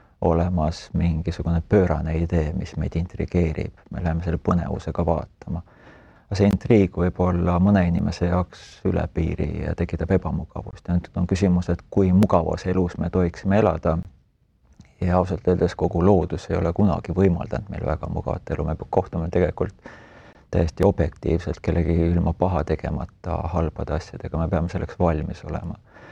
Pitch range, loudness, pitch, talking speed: 85-95 Hz, -23 LUFS, 90 Hz, 145 wpm